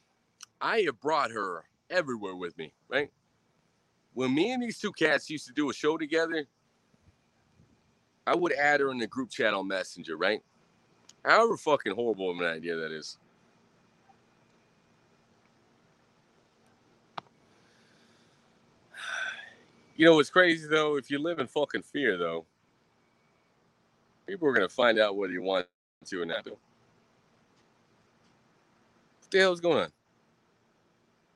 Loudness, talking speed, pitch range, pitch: -28 LUFS, 130 wpm, 95-160 Hz, 140 Hz